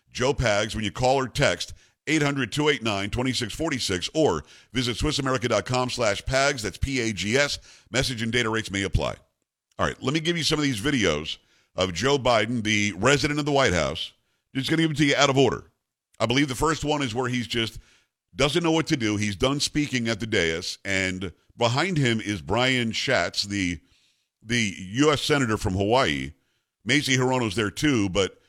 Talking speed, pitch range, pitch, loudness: 195 wpm, 105-140 Hz, 125 Hz, -24 LUFS